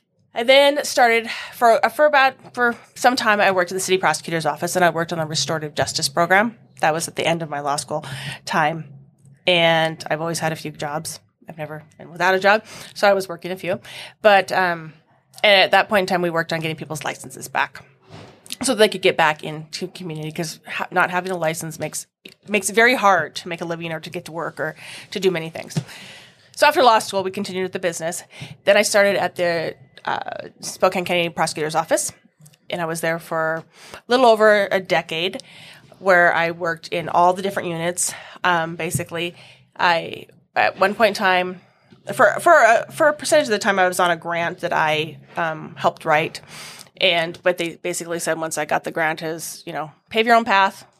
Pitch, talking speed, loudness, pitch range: 175 Hz, 215 wpm, -19 LUFS, 160-195 Hz